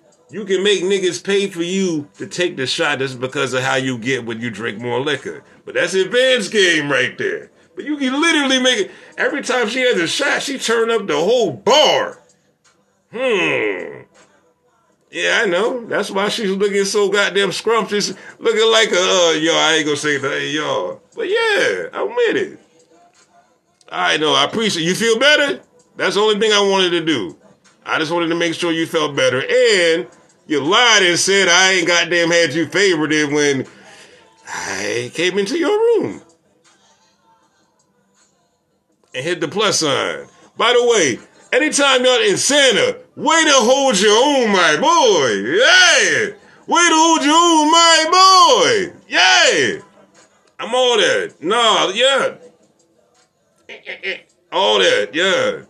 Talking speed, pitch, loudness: 165 wpm, 260 Hz, -15 LUFS